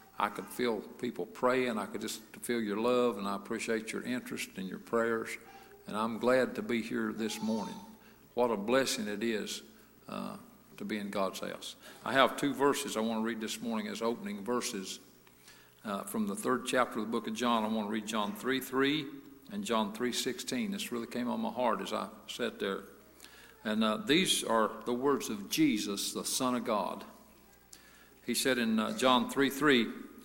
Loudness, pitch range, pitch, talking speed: -33 LUFS, 110-135 Hz, 120 Hz, 200 wpm